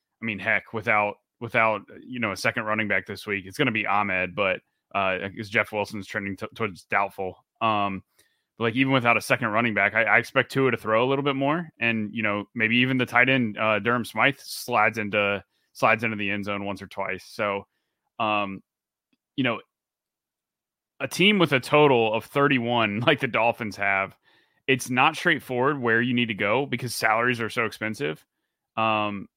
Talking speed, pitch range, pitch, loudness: 200 wpm, 105-125 Hz, 110 Hz, -24 LUFS